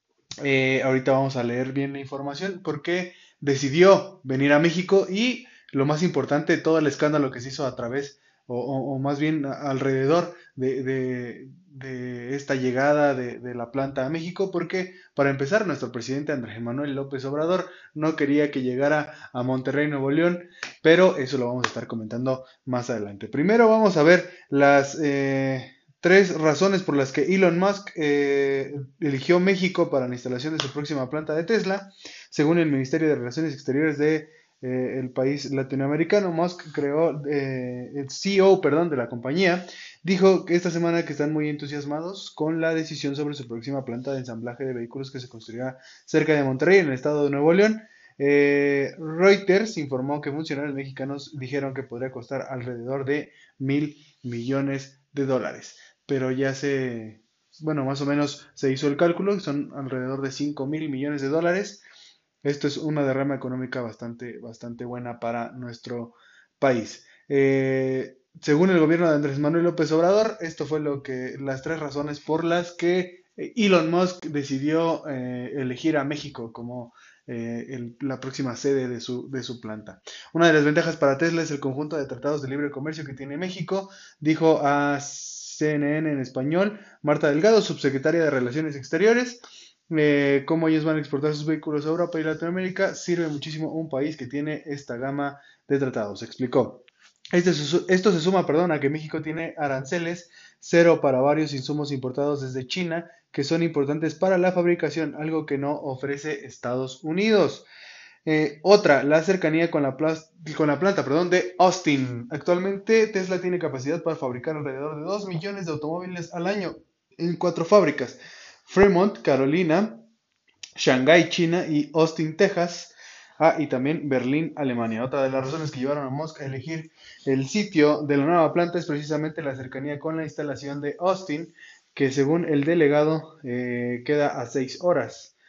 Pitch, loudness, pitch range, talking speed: 145 Hz, -24 LUFS, 135-165 Hz, 170 wpm